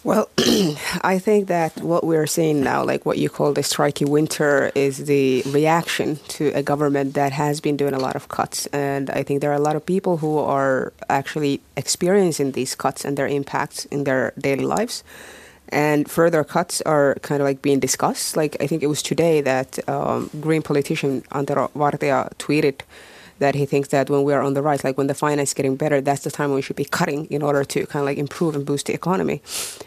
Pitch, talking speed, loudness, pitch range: 145 Hz, 220 wpm, -21 LUFS, 140-155 Hz